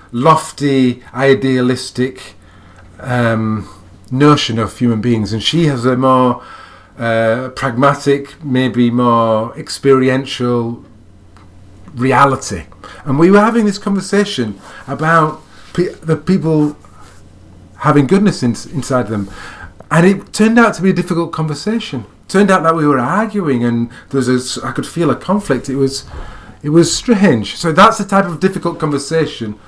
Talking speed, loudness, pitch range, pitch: 140 wpm, -14 LUFS, 115-165 Hz, 130 Hz